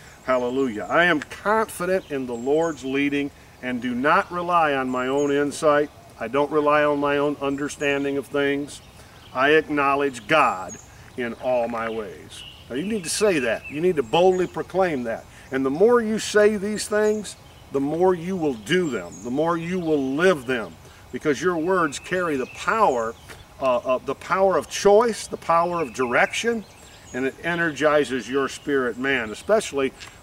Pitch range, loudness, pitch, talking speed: 130-180 Hz, -22 LUFS, 145 Hz, 170 wpm